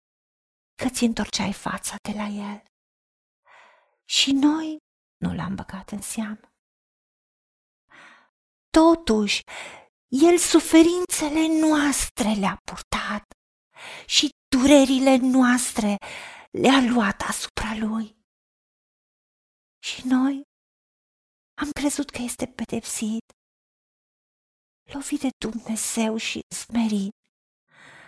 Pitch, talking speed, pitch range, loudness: 255 Hz, 85 wpm, 220-295 Hz, -22 LUFS